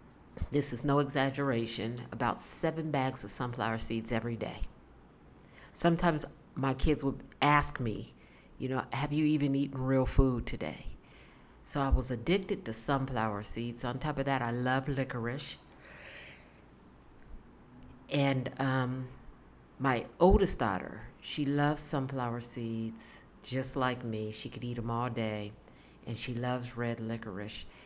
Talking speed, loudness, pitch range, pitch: 140 wpm, -33 LUFS, 115-140 Hz, 125 Hz